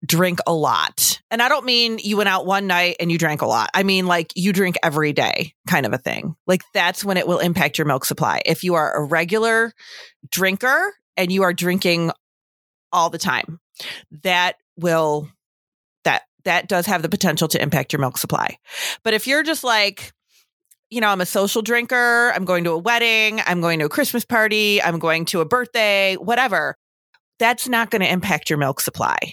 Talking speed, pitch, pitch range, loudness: 205 wpm, 185 Hz, 165-225 Hz, -19 LUFS